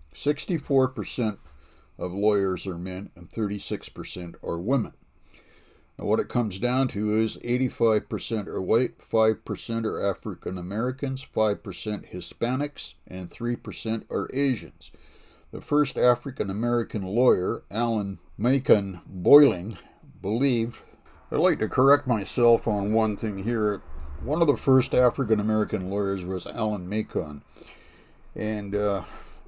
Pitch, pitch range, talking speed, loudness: 110 Hz, 95-120 Hz, 130 wpm, -26 LUFS